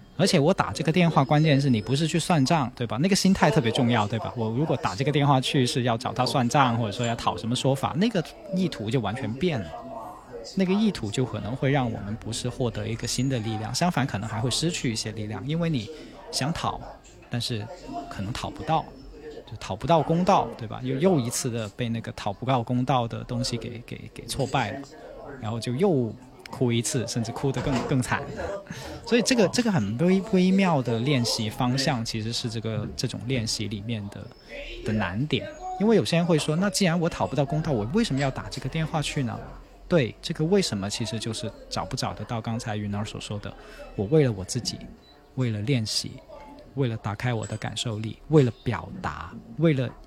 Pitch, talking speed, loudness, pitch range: 125 Hz, 305 characters per minute, -26 LUFS, 115-150 Hz